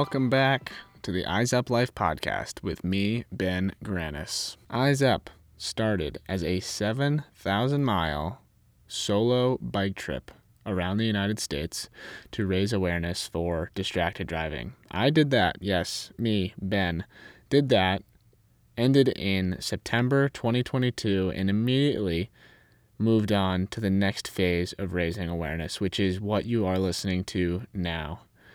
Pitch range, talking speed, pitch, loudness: 90-120 Hz, 130 wpm, 100 Hz, -27 LUFS